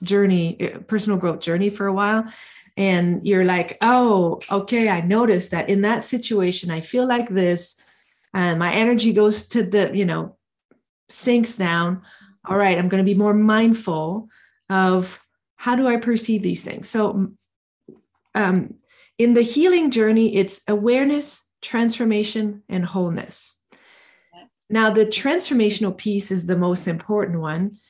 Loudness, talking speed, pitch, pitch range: -20 LUFS, 145 wpm, 205 Hz, 185-225 Hz